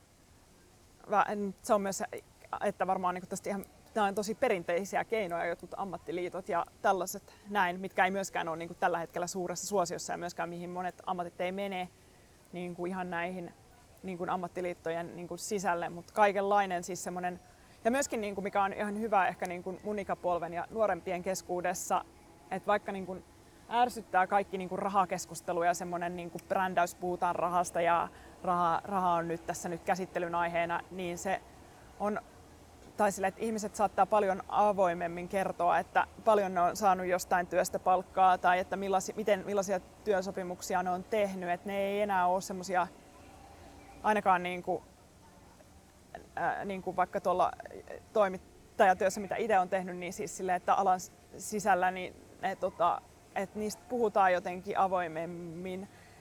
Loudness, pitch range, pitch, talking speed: -32 LUFS, 175-200 Hz, 185 Hz, 135 wpm